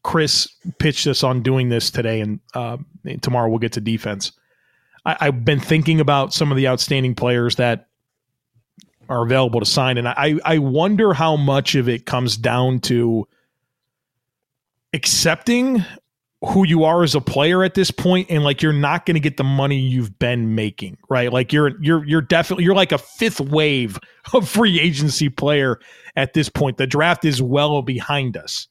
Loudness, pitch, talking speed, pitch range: -18 LUFS, 140 Hz, 180 wpm, 125-160 Hz